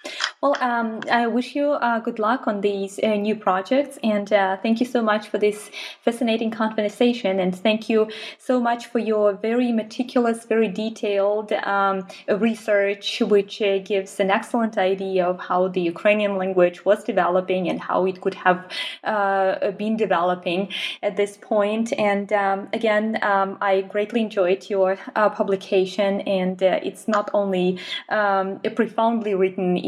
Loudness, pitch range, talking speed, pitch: -22 LUFS, 195-225 Hz, 160 wpm, 205 Hz